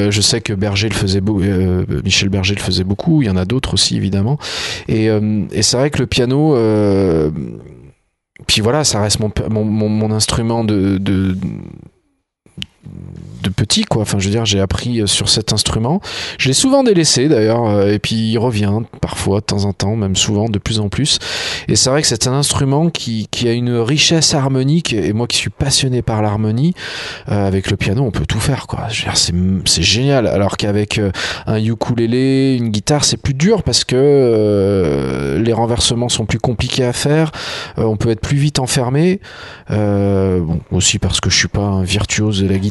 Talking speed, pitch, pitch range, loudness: 205 wpm, 110 Hz, 100-130 Hz, -15 LUFS